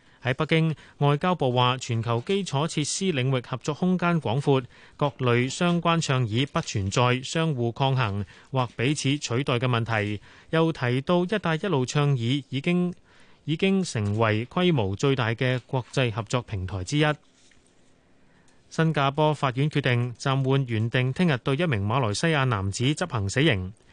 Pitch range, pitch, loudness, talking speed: 120-155 Hz, 135 Hz, -25 LUFS, 240 characters per minute